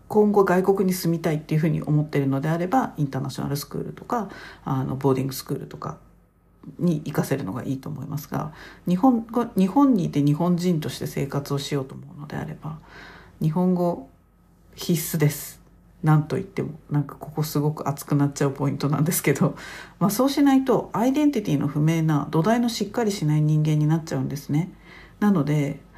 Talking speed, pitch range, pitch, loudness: 420 characters per minute, 140-180 Hz, 155 Hz, -23 LUFS